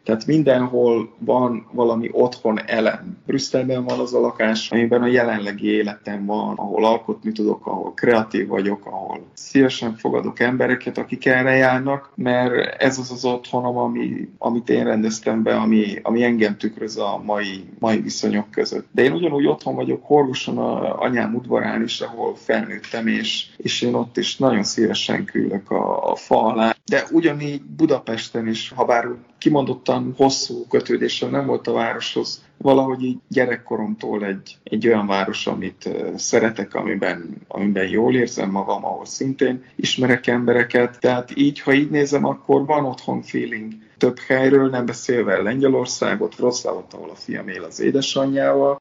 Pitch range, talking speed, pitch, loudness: 110-130 Hz, 150 wpm, 120 Hz, -20 LUFS